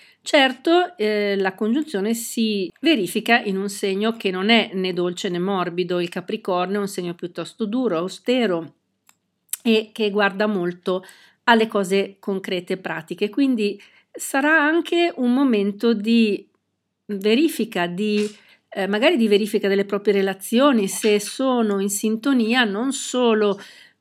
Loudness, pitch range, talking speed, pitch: -21 LUFS, 195-235 Hz, 135 wpm, 210 Hz